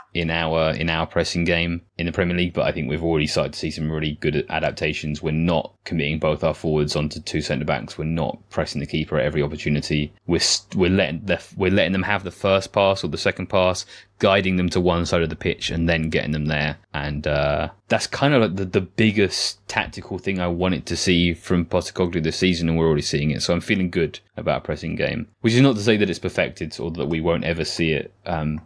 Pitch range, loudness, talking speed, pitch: 75-90 Hz, -22 LUFS, 245 wpm, 85 Hz